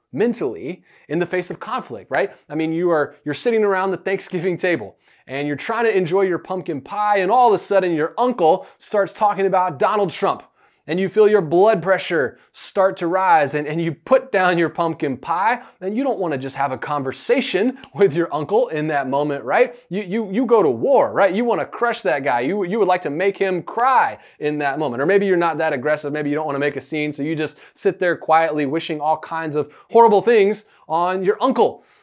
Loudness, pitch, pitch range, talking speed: -19 LUFS, 180 Hz, 150-200 Hz, 230 wpm